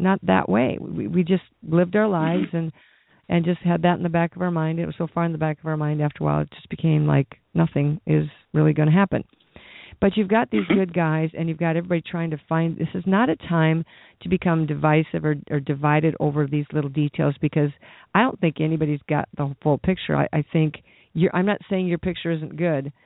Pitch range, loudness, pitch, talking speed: 150-175 Hz, -22 LUFS, 160 Hz, 240 wpm